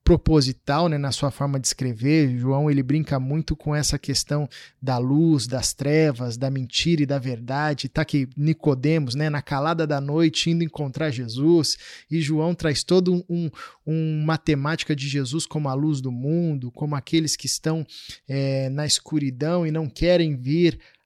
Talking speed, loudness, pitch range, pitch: 170 wpm, -23 LUFS, 135-160 Hz, 150 Hz